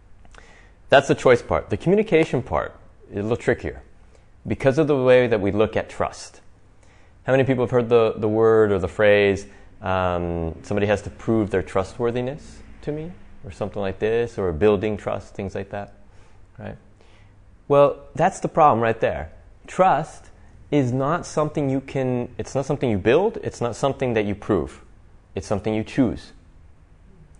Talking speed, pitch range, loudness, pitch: 170 wpm, 95-125 Hz, -21 LUFS, 105 Hz